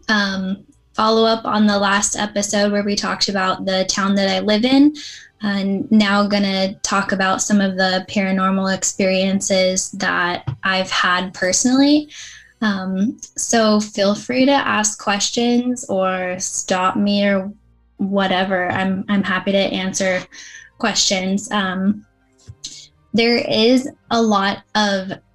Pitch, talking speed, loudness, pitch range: 200 Hz, 135 wpm, -17 LUFS, 190-215 Hz